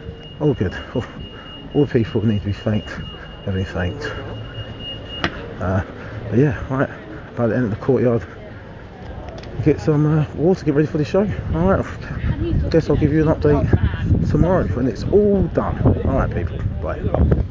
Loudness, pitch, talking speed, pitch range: -20 LUFS, 115 Hz, 170 wpm, 100-145 Hz